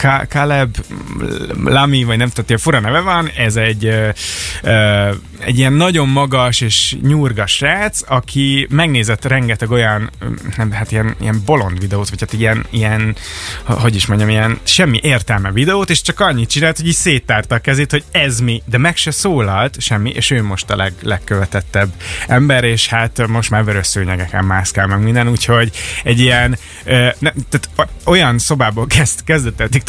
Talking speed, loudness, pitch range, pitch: 170 wpm, -13 LUFS, 105-135 Hz, 115 Hz